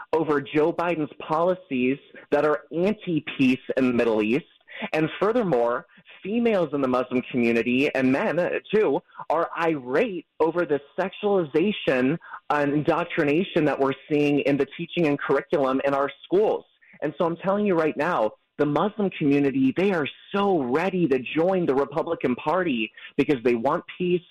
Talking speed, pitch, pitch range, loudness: 155 wpm, 150 Hz, 135-180 Hz, -24 LUFS